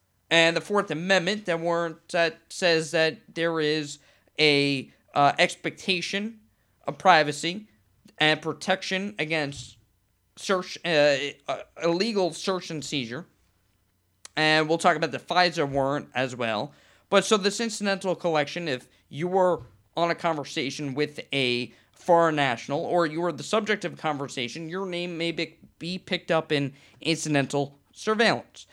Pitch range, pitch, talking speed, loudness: 140-175 Hz, 160 Hz, 140 wpm, -25 LUFS